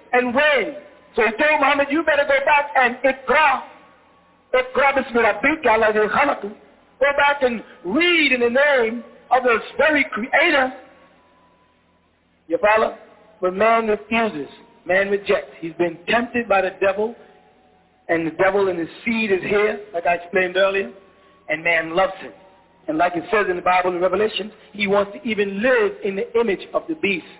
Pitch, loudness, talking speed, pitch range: 220 Hz, -19 LUFS, 160 wpm, 190-270 Hz